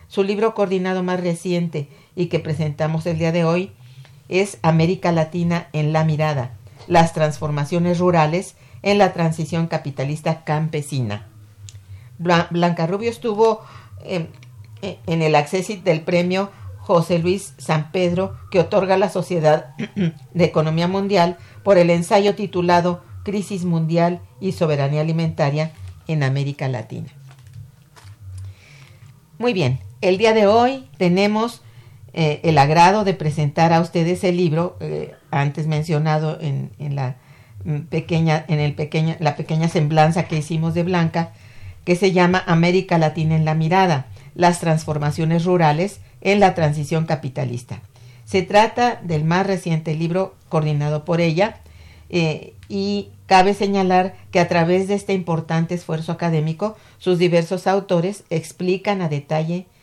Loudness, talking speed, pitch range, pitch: -19 LUFS, 135 wpm, 150-180 Hz, 165 Hz